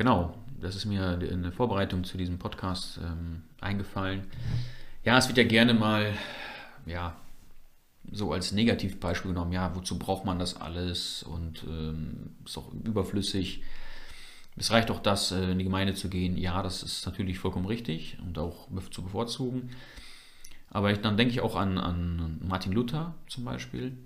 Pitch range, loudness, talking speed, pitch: 90-110 Hz, -30 LUFS, 160 wpm, 95 Hz